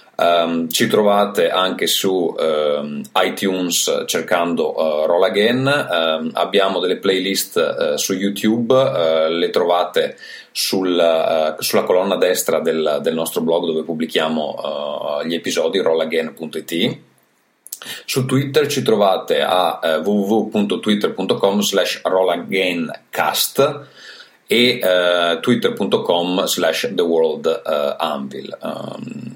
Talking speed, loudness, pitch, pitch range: 100 wpm, -17 LUFS, 95 Hz, 85-130 Hz